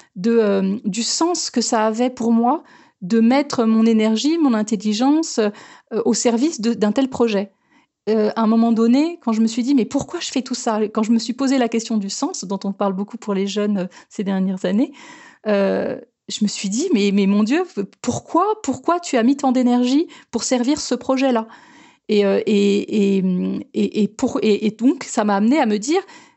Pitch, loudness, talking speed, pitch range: 230 Hz, -19 LUFS, 215 wpm, 210-270 Hz